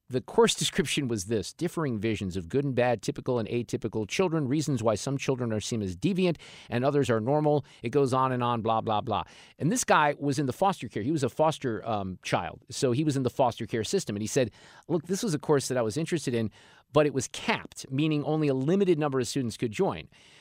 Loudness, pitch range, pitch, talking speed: -28 LUFS, 115-150 Hz, 135 Hz, 245 wpm